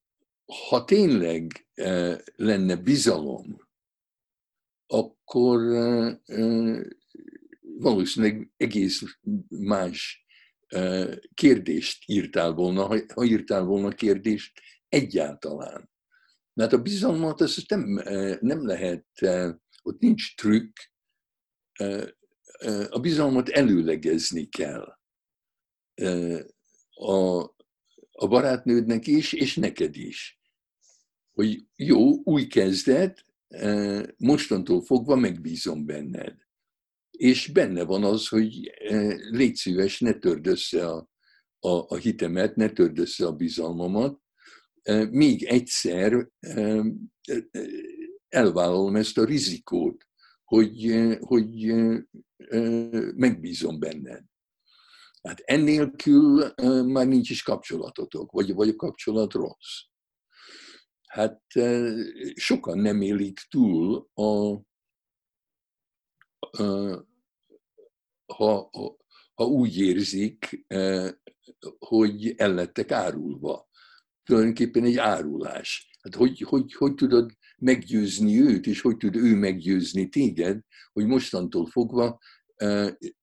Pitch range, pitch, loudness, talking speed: 100-165 Hz, 115 Hz, -24 LUFS, 90 wpm